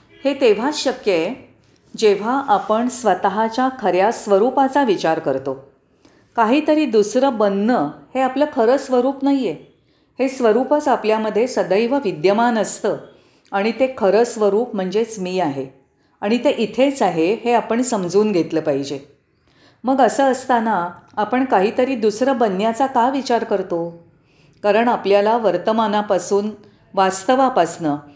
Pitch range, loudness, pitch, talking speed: 190-255 Hz, -18 LUFS, 220 Hz, 120 wpm